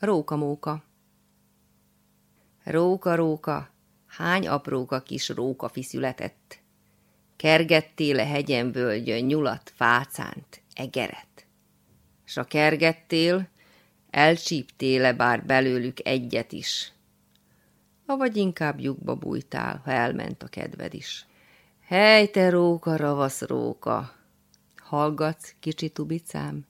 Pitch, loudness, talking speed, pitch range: 145 Hz, -25 LUFS, 95 wpm, 115-160 Hz